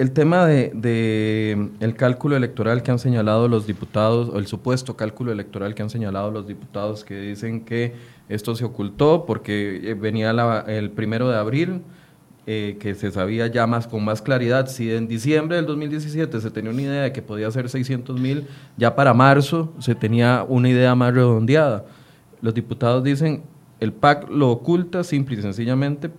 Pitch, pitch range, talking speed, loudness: 120 Hz, 110-140 Hz, 180 wpm, -21 LUFS